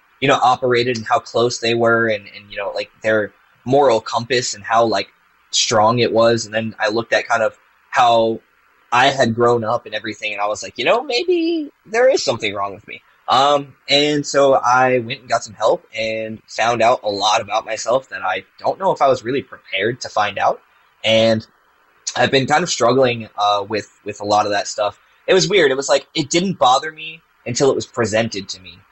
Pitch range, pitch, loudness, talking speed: 110-135 Hz, 115 Hz, -17 LUFS, 220 wpm